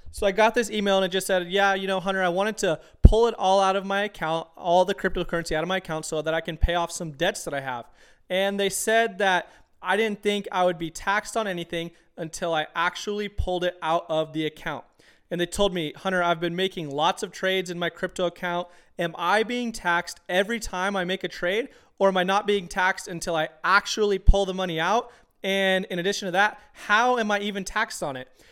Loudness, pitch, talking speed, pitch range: -25 LUFS, 185 Hz, 240 wpm, 170-200 Hz